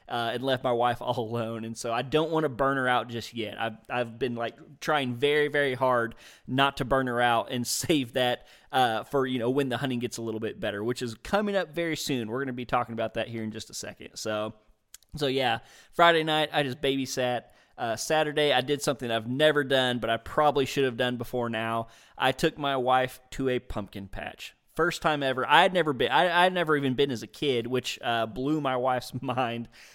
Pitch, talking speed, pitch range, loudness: 125 Hz, 235 wpm, 115-140 Hz, -27 LUFS